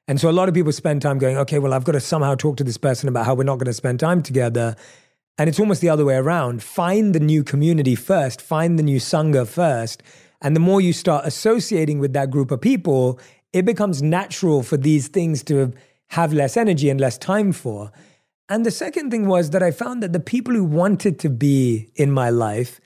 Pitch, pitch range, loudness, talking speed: 150 Hz, 130-180 Hz, -19 LUFS, 230 wpm